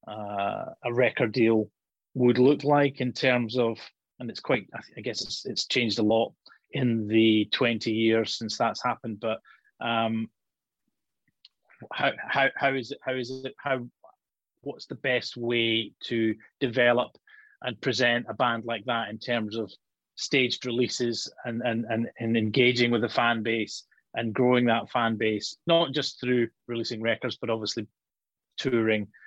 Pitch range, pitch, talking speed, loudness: 110-125 Hz, 120 Hz, 160 wpm, -27 LUFS